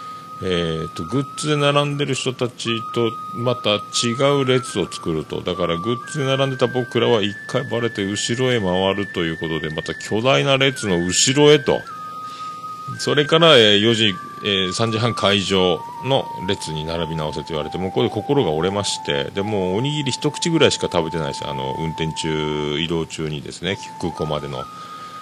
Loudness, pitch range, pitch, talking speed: -19 LUFS, 85-140 Hz, 115 Hz, 325 characters per minute